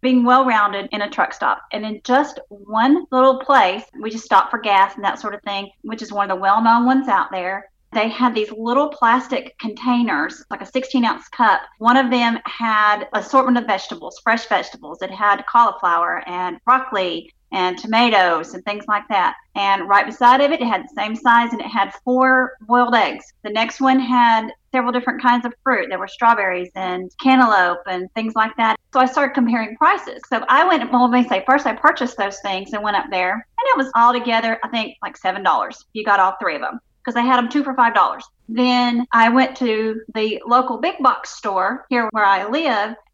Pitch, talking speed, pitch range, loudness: 230 Hz, 215 wpm, 205-255 Hz, -17 LUFS